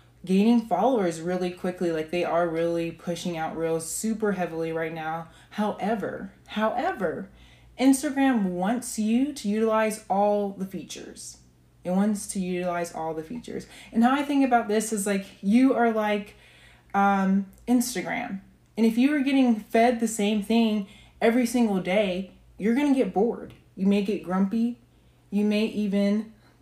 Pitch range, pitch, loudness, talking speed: 180-230 Hz, 205 Hz, -25 LUFS, 155 wpm